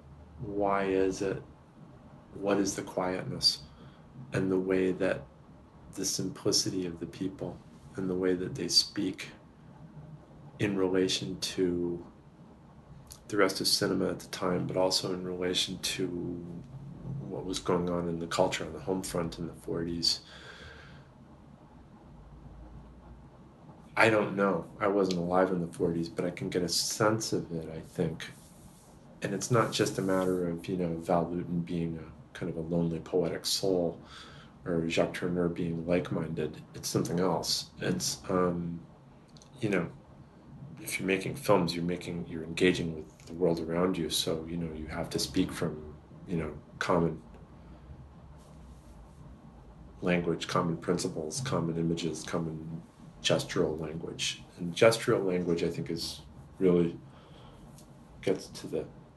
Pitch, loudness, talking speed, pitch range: 85 Hz, -31 LUFS, 145 wpm, 85-95 Hz